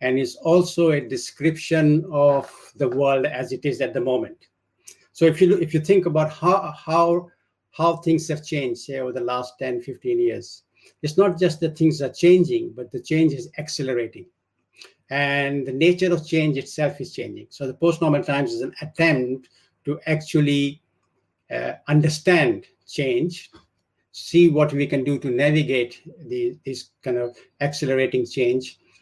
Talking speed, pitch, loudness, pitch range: 165 wpm, 150 Hz, -21 LUFS, 135-170 Hz